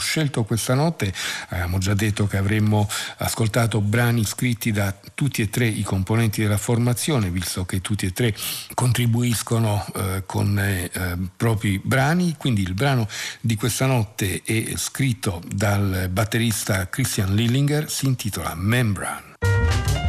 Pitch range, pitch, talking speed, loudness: 100-120 Hz, 110 Hz, 135 wpm, -22 LUFS